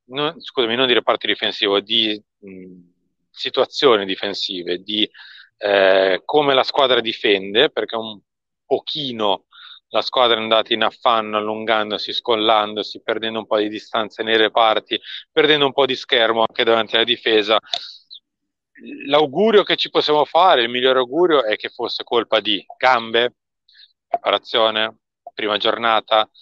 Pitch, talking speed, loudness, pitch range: 110 Hz, 135 wpm, -18 LUFS, 105-125 Hz